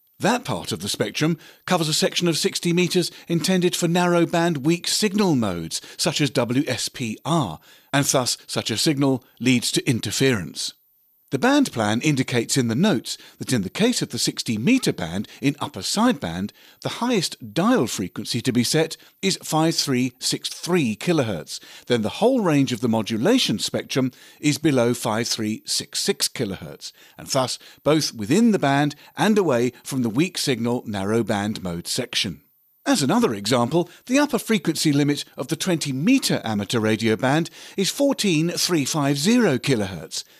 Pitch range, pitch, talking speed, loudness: 120-175 Hz, 150 Hz, 155 wpm, -22 LUFS